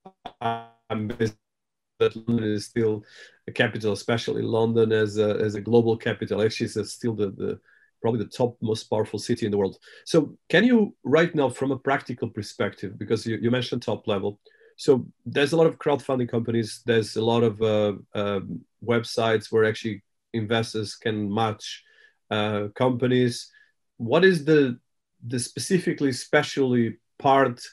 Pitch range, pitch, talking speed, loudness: 110-135 Hz, 115 Hz, 155 wpm, -25 LUFS